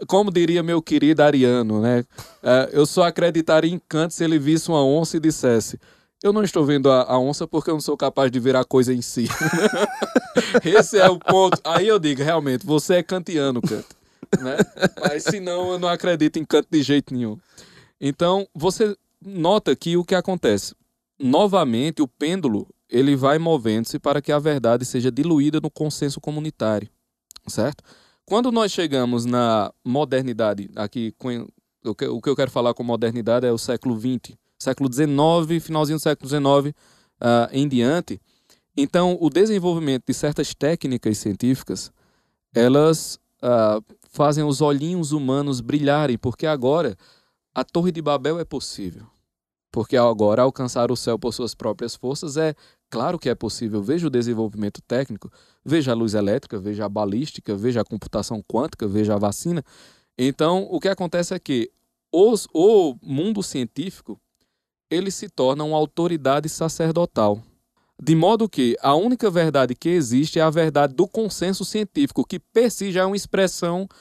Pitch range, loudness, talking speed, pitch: 125-170 Hz, -21 LUFS, 165 wpm, 150 Hz